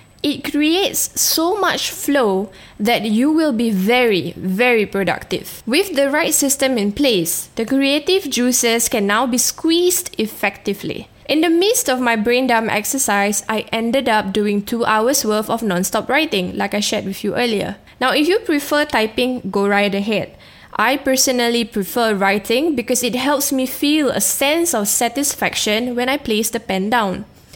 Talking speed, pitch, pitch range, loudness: 170 wpm, 240 Hz, 210-275 Hz, -17 LUFS